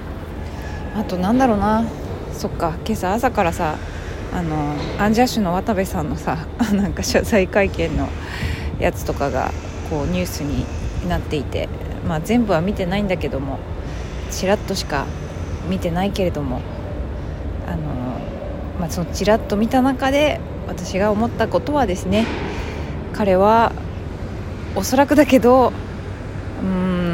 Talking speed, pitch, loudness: 260 characters per minute, 100 Hz, -21 LUFS